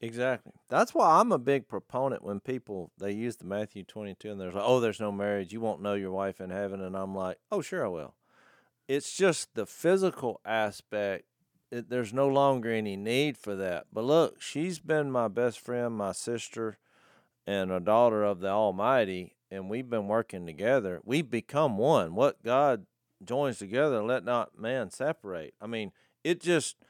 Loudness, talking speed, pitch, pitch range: -30 LUFS, 185 wpm, 110 Hz, 100-125 Hz